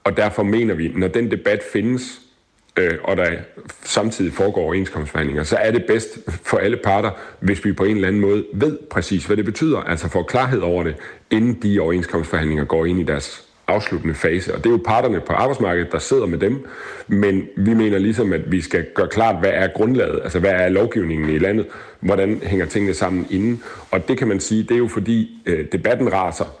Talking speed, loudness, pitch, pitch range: 210 wpm, -19 LUFS, 100 Hz, 85-110 Hz